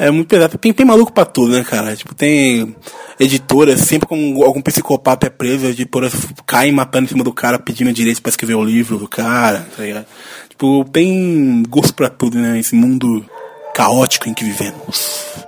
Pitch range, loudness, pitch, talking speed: 120-150 Hz, -13 LUFS, 130 Hz, 180 wpm